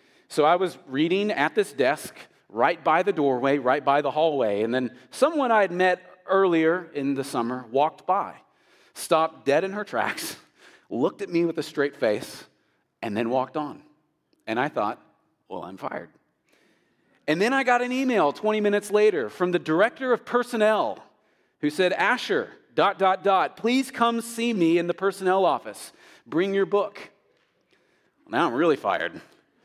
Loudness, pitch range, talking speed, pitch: -24 LUFS, 155-215 Hz, 170 wpm, 185 Hz